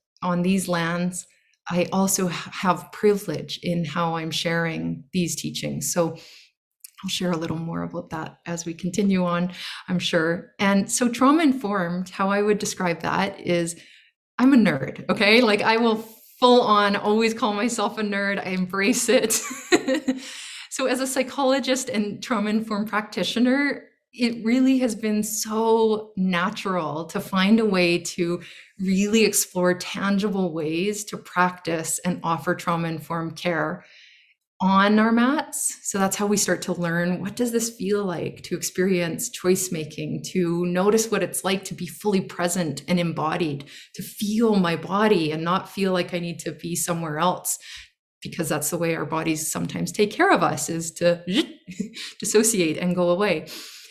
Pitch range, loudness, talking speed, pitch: 175-215 Hz, -23 LUFS, 160 wpm, 190 Hz